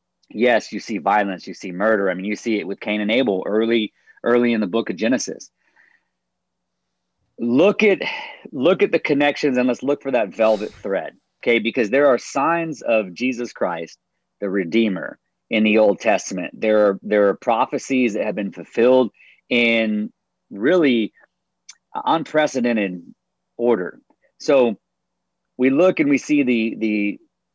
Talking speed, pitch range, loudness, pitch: 155 wpm, 105-130 Hz, -19 LUFS, 115 Hz